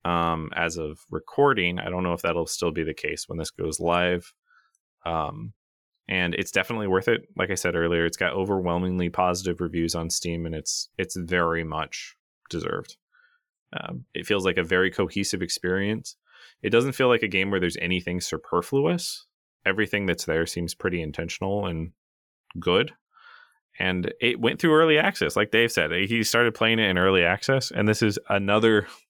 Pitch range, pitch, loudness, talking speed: 85-110 Hz, 90 Hz, -25 LUFS, 175 wpm